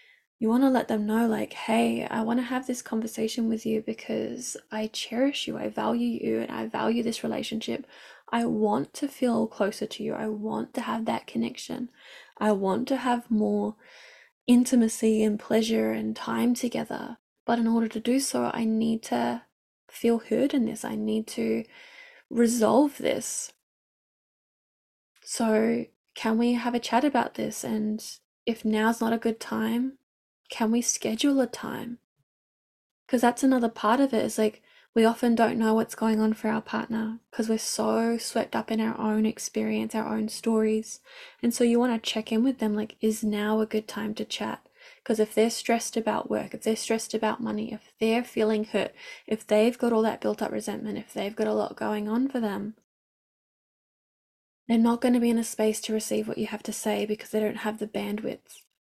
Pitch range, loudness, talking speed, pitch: 215-235 Hz, -27 LUFS, 195 wpm, 225 Hz